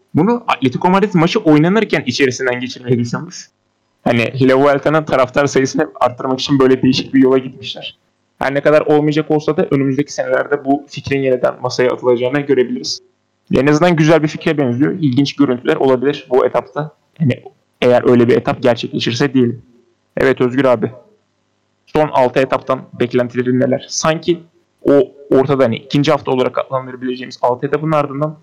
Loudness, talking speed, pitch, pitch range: -15 LUFS, 150 wpm, 135 Hz, 125-150 Hz